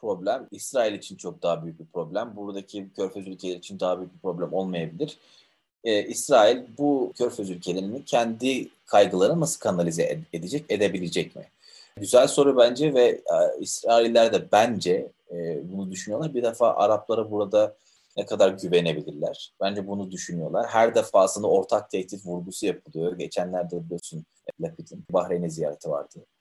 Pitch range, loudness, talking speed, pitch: 90-115 Hz, -25 LUFS, 140 wpm, 100 Hz